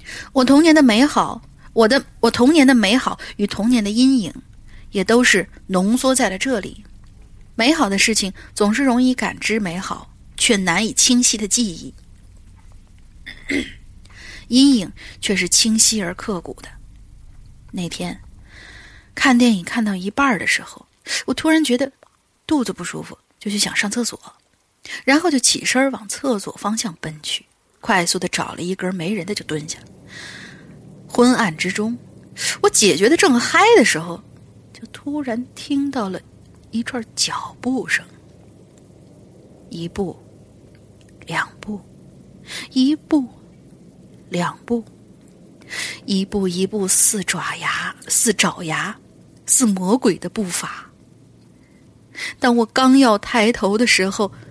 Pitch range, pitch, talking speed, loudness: 170-245 Hz, 210 Hz, 185 characters per minute, -17 LUFS